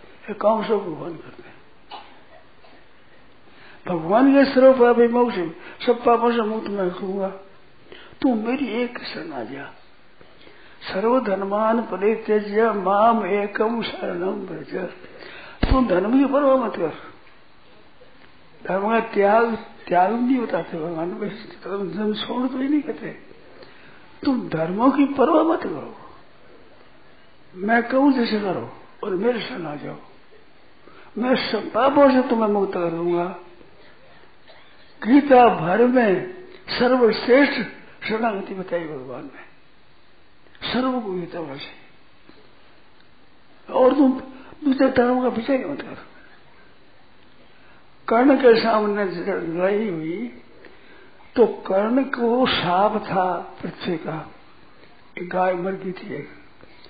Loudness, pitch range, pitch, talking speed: -21 LUFS, 190-255 Hz, 220 Hz, 115 wpm